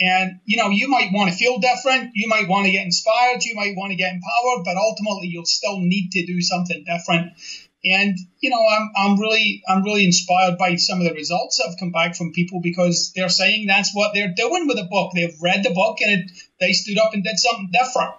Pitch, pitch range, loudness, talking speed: 190 Hz, 180-215 Hz, -18 LUFS, 240 wpm